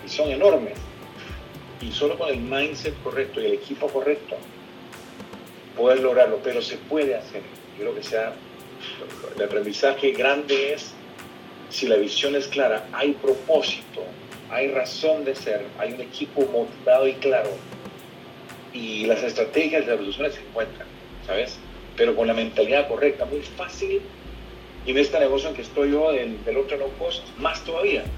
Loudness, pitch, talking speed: -23 LUFS, 140 Hz, 160 wpm